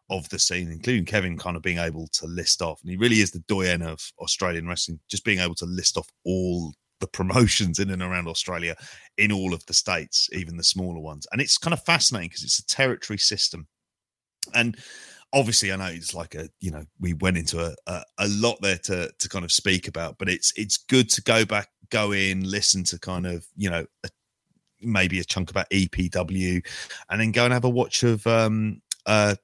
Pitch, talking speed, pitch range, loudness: 95 Hz, 220 wpm, 85-105 Hz, -23 LUFS